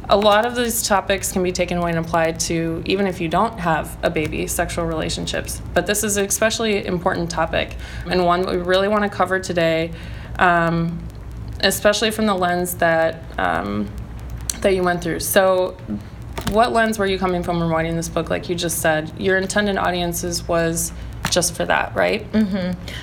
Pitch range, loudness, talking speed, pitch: 165-195 Hz, -20 LUFS, 190 wpm, 175 Hz